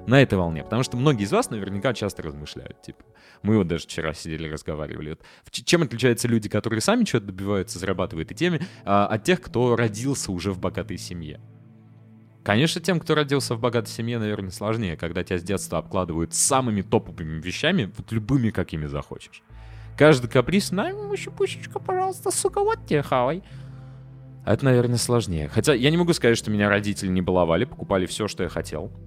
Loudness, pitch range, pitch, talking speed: -24 LUFS, 95-130 Hz, 110 Hz, 175 wpm